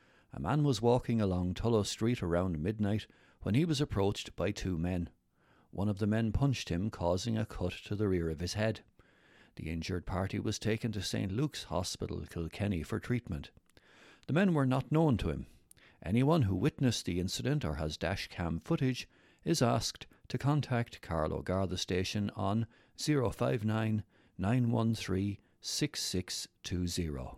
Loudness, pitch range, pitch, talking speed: -34 LUFS, 90-120 Hz, 105 Hz, 155 wpm